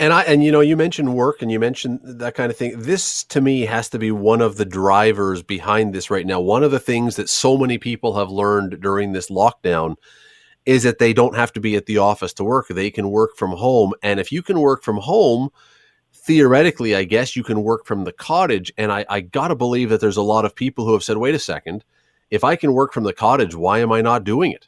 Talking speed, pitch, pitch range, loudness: 255 wpm, 115 Hz, 105-130 Hz, -18 LUFS